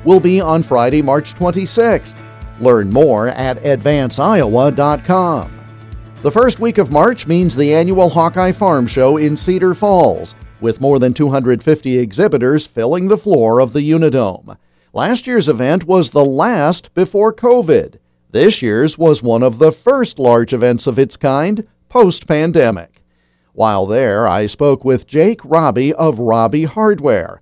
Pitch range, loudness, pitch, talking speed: 125-180 Hz, -13 LUFS, 150 Hz, 145 wpm